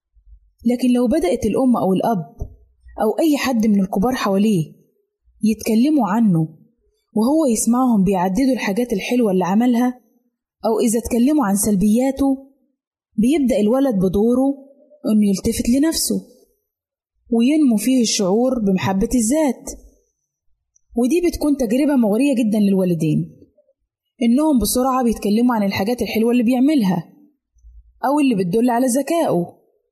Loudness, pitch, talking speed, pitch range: -18 LUFS, 240 Hz, 110 wpm, 210-270 Hz